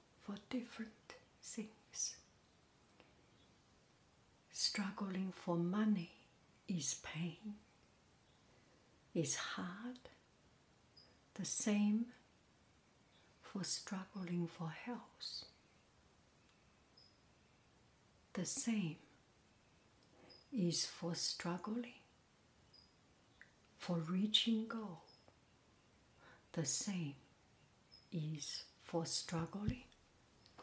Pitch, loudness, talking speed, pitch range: 190 Hz, -42 LUFS, 55 wpm, 165-215 Hz